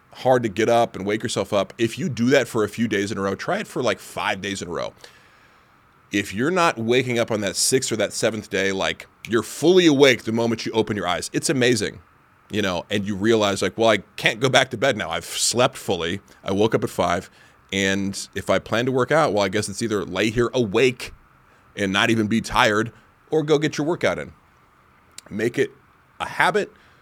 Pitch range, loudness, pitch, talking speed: 100-125 Hz, -21 LUFS, 110 Hz, 230 wpm